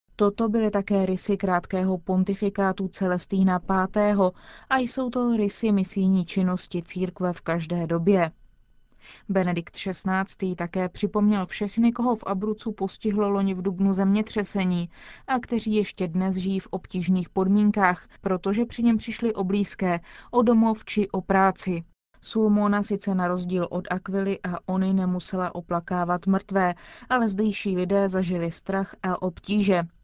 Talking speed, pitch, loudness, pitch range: 135 wpm, 195 Hz, -25 LUFS, 185-210 Hz